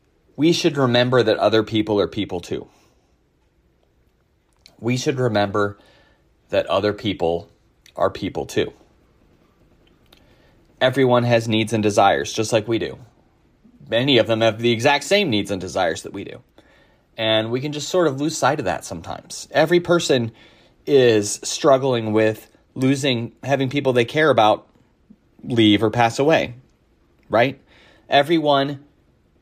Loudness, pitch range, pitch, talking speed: -19 LUFS, 110-140 Hz, 120 Hz, 140 wpm